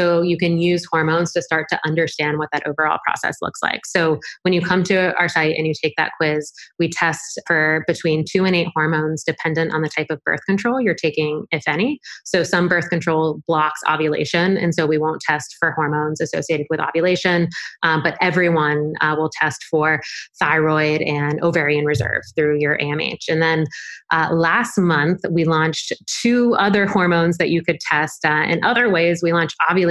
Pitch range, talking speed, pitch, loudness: 155-175 Hz, 195 wpm, 160 Hz, -18 LUFS